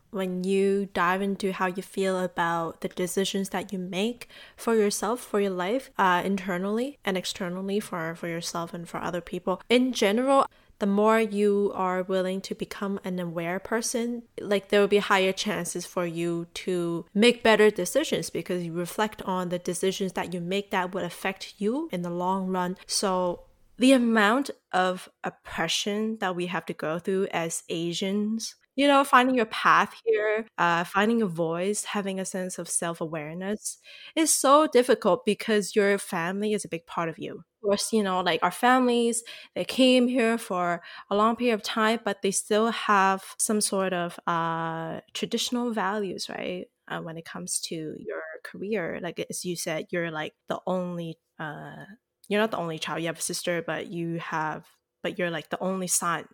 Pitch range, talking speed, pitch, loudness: 175-215 Hz, 180 wpm, 190 Hz, -26 LUFS